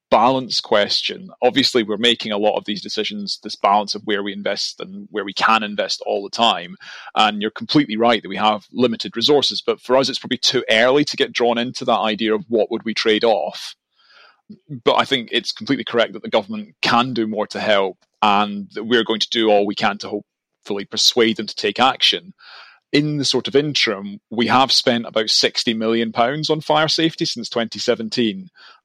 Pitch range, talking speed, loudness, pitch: 105-125 Hz, 205 wpm, -18 LUFS, 115 Hz